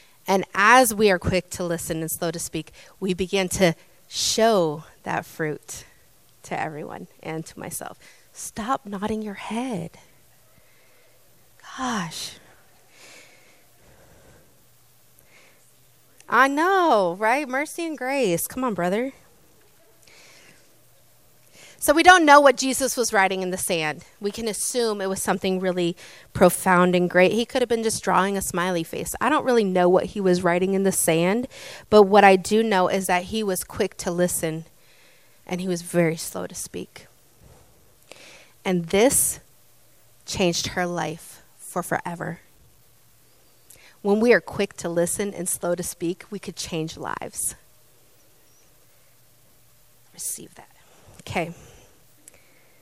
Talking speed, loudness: 135 wpm, -22 LUFS